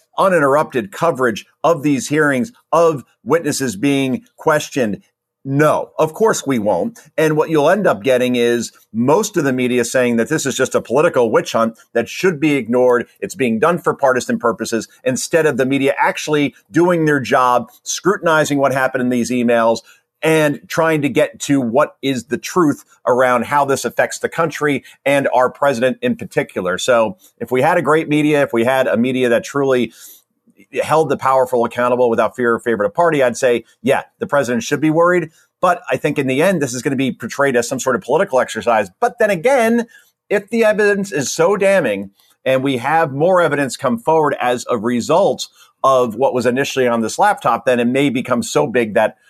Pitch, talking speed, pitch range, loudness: 140 Hz, 195 wpm, 125-155 Hz, -16 LUFS